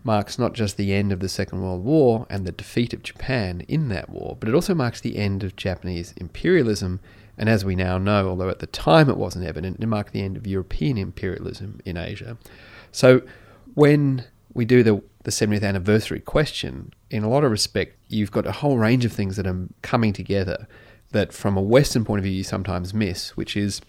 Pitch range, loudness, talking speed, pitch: 95-115 Hz, -22 LUFS, 215 wpm, 105 Hz